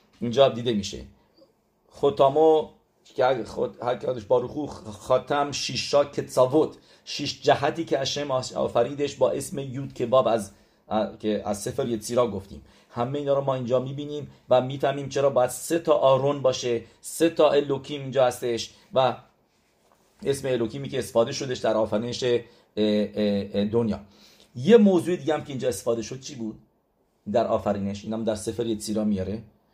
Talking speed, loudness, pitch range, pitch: 145 wpm, -25 LUFS, 110-140 Hz, 125 Hz